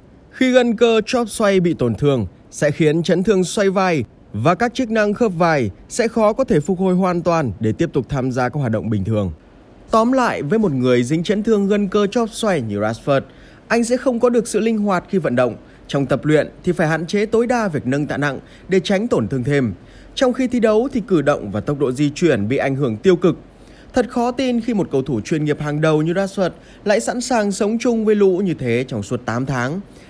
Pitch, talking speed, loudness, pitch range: 175 Hz, 245 wpm, -18 LUFS, 135-220 Hz